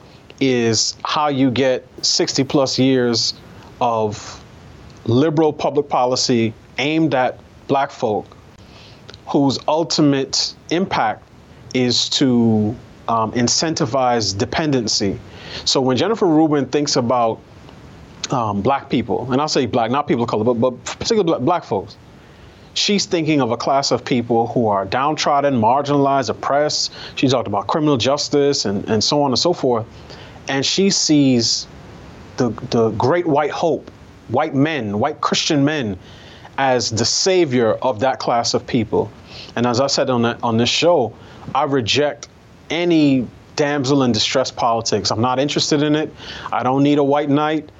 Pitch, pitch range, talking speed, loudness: 130 Hz, 115-145 Hz, 145 wpm, -18 LUFS